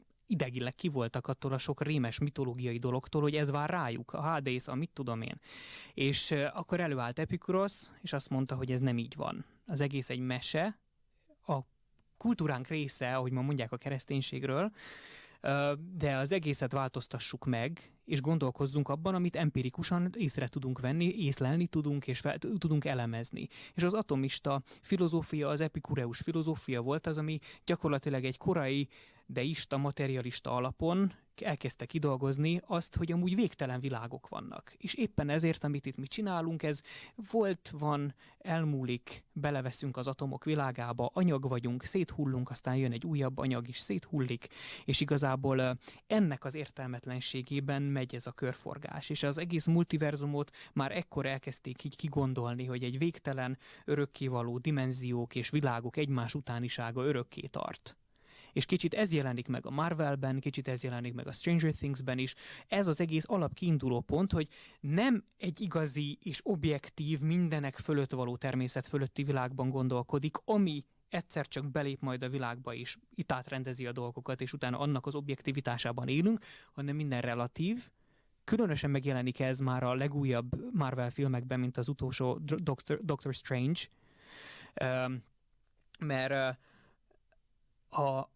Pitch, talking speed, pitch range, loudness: 140 Hz, 145 wpm, 130-155 Hz, -35 LUFS